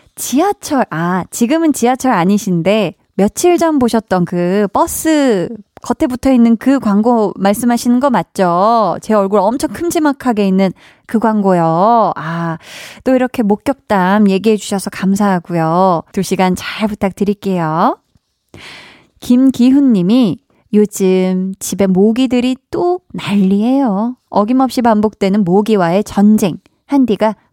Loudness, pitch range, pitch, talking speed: -13 LUFS, 195-250 Hz, 210 Hz, 260 characters per minute